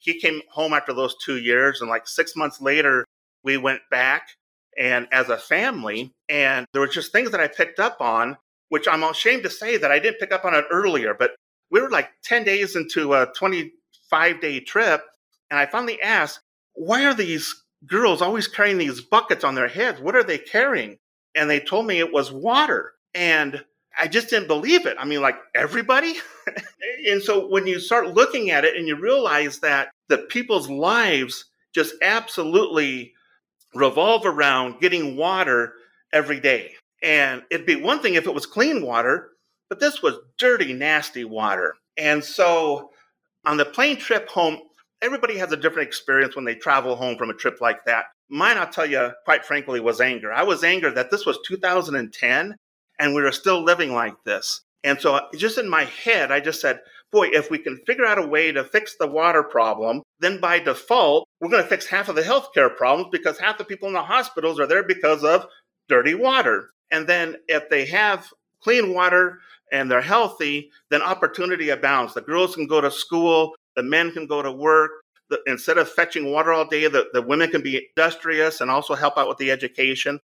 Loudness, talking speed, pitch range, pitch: -20 LUFS, 195 wpm, 145-215 Hz, 160 Hz